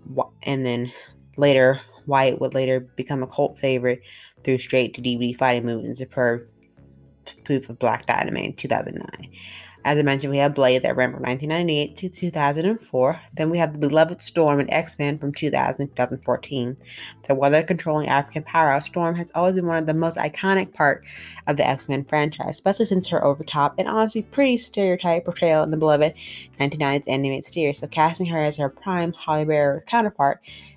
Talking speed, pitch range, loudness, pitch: 175 wpm, 130-160 Hz, -22 LUFS, 145 Hz